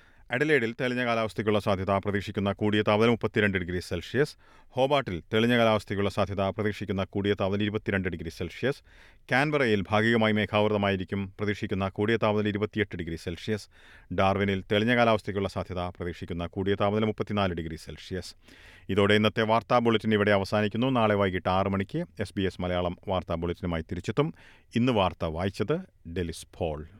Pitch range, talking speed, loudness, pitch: 90-110 Hz, 135 wpm, -27 LUFS, 100 Hz